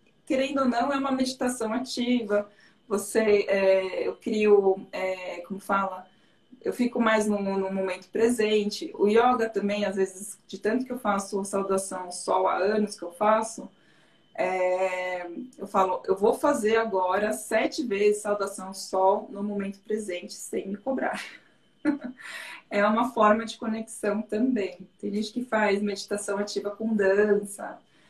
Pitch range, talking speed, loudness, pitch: 195-225 Hz, 150 wpm, -26 LUFS, 205 Hz